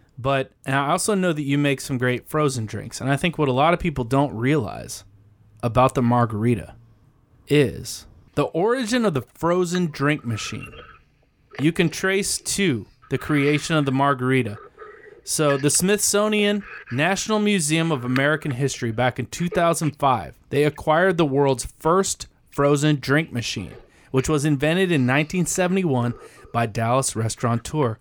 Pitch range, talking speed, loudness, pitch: 125-170 Hz, 150 wpm, -22 LUFS, 140 Hz